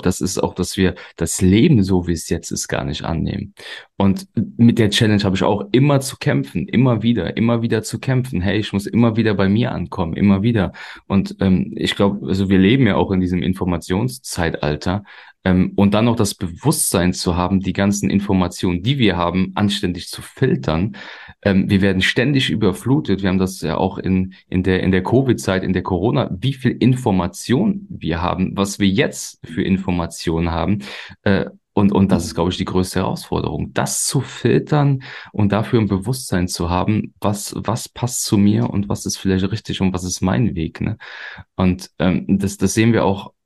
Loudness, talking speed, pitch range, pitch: -18 LUFS, 190 wpm, 90-115 Hz, 95 Hz